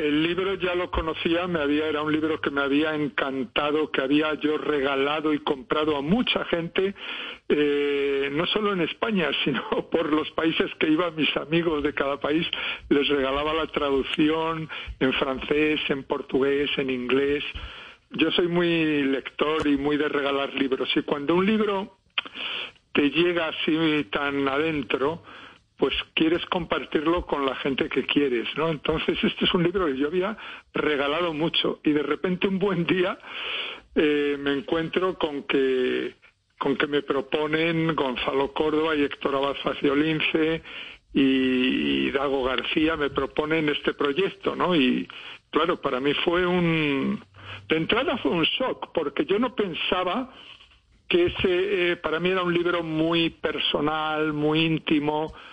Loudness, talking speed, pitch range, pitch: -24 LUFS, 155 wpm, 140-175 Hz, 155 Hz